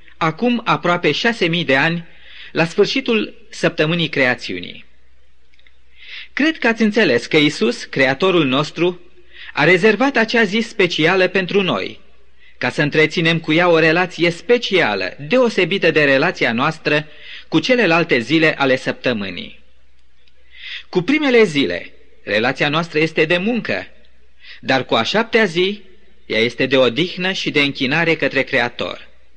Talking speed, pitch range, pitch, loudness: 130 wpm, 140-200 Hz, 165 Hz, -16 LUFS